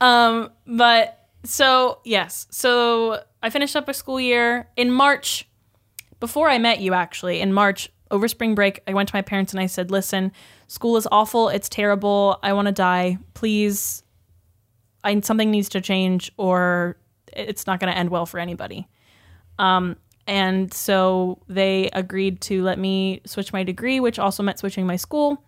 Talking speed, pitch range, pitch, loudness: 170 wpm, 185-230 Hz, 195 Hz, -20 LUFS